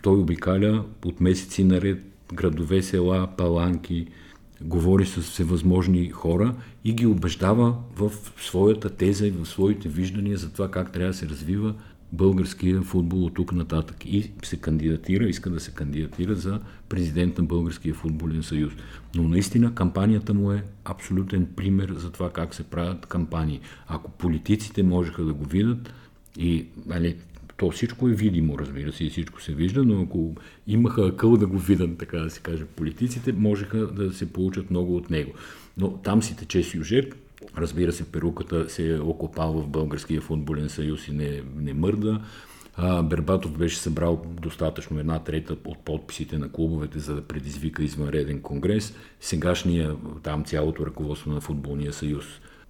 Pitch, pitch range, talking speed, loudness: 85 Hz, 80-95 Hz, 155 wpm, -25 LUFS